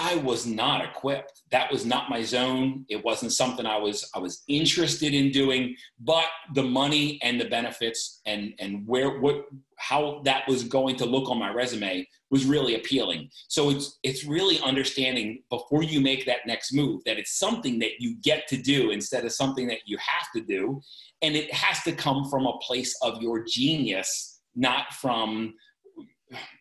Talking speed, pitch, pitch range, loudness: 185 wpm, 135 Hz, 120-145 Hz, -26 LUFS